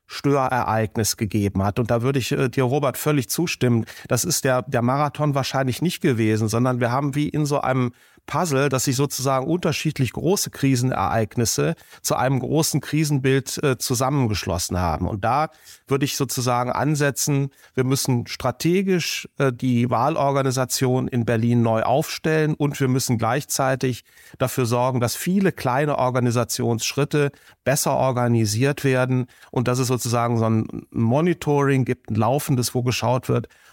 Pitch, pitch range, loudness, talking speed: 130 Hz, 120-145 Hz, -22 LUFS, 150 wpm